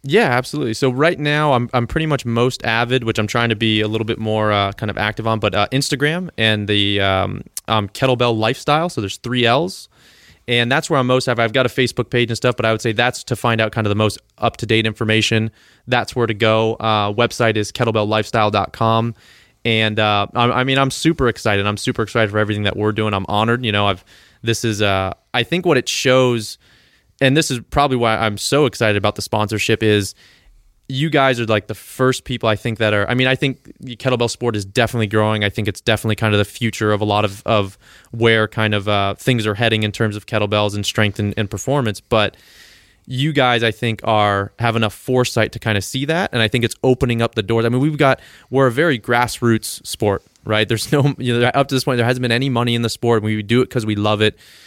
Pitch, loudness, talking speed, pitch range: 115 Hz, -17 LUFS, 240 wpm, 105-125 Hz